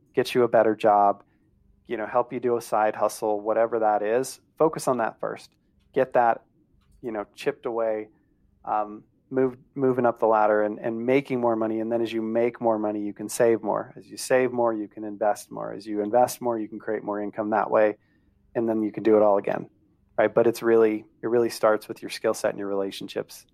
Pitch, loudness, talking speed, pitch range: 110 Hz, -25 LUFS, 225 wpm, 105-120 Hz